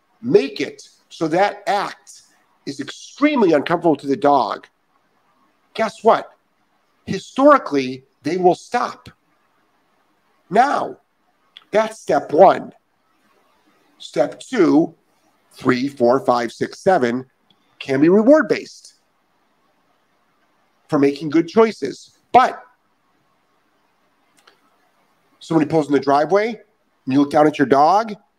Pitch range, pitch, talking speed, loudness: 140-220 Hz, 165 Hz, 105 wpm, -17 LUFS